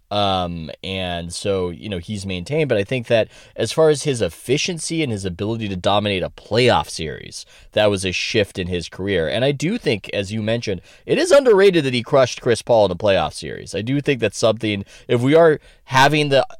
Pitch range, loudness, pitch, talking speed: 95-140 Hz, -19 LUFS, 110 Hz, 215 wpm